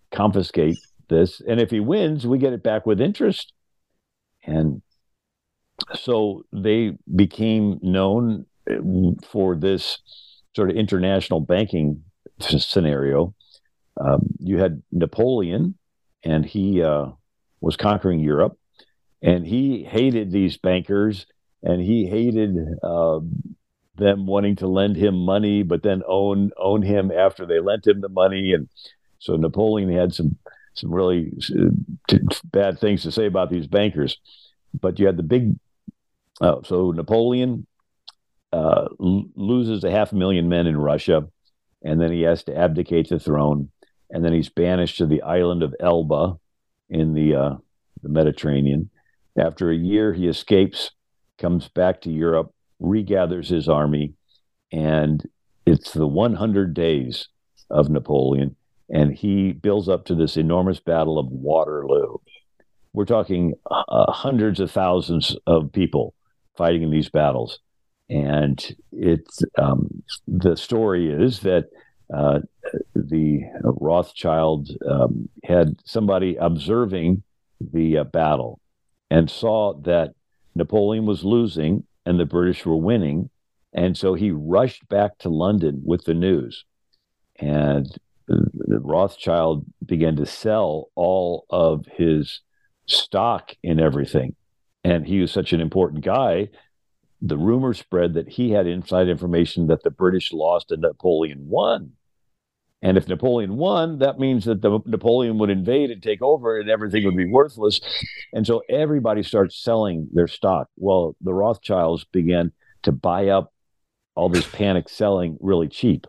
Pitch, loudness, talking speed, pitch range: 90 Hz, -21 LUFS, 135 wpm, 80-105 Hz